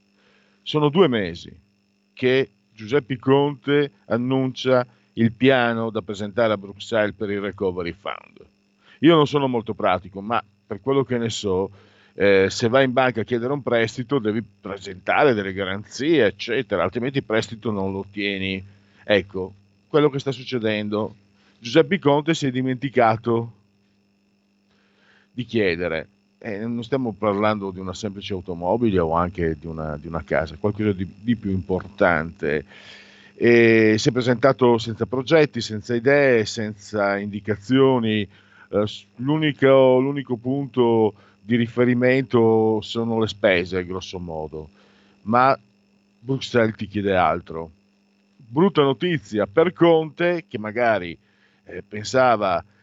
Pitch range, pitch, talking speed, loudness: 100-125 Hz, 110 Hz, 130 wpm, -21 LUFS